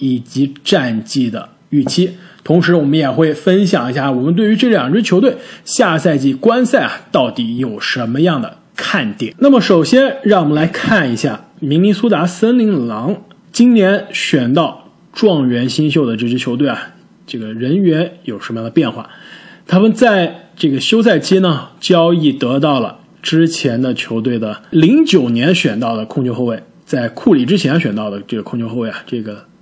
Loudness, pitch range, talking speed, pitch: -14 LUFS, 130-205 Hz, 265 characters per minute, 165 Hz